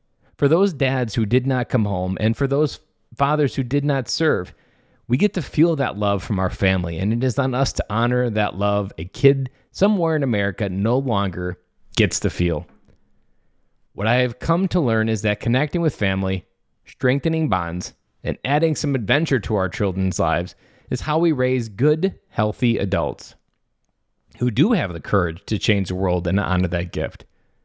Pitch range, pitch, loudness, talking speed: 95-135 Hz, 115 Hz, -21 LUFS, 185 wpm